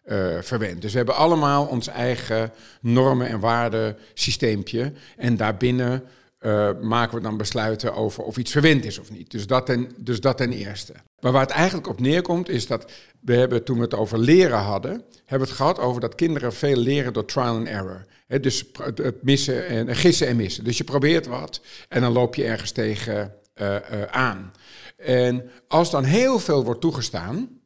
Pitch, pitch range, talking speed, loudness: 120 Hz, 110-135 Hz, 195 wpm, -22 LUFS